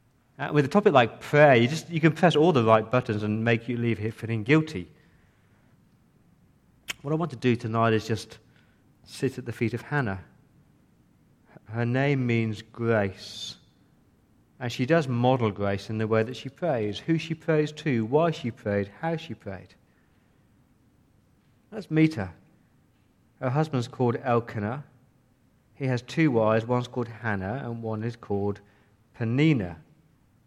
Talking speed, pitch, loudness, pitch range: 160 wpm, 120 Hz, -26 LUFS, 110-140 Hz